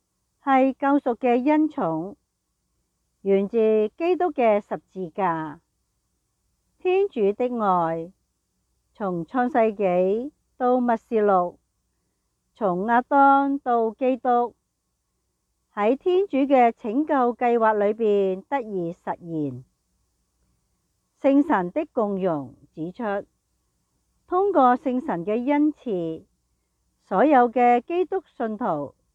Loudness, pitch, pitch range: -23 LUFS, 230 Hz, 185-265 Hz